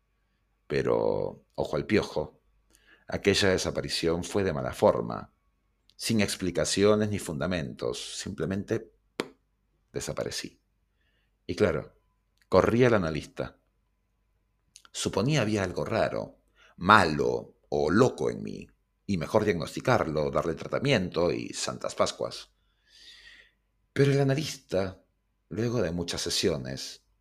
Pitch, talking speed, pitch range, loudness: 100 Hz, 100 wpm, 85-115 Hz, -28 LUFS